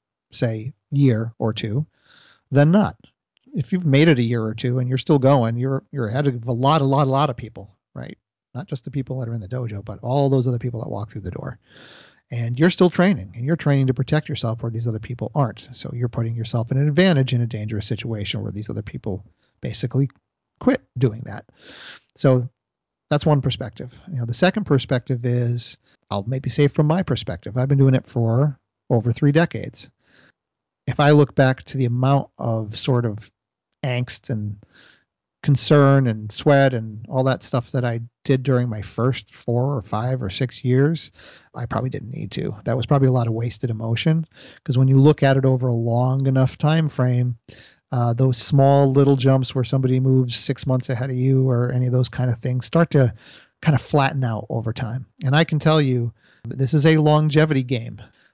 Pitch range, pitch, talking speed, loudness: 115-140 Hz, 130 Hz, 210 wpm, -20 LUFS